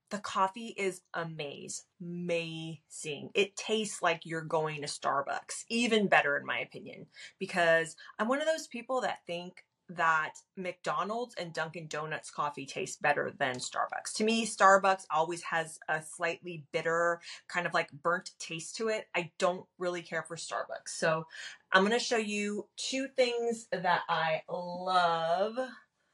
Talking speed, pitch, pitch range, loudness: 150 wpm, 175 Hz, 165-215 Hz, -32 LUFS